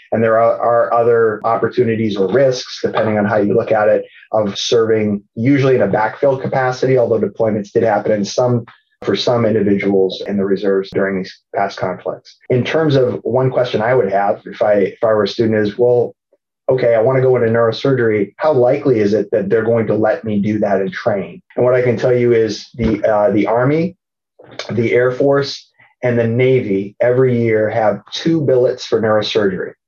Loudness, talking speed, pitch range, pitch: -15 LUFS, 200 wpm, 105-125 Hz, 115 Hz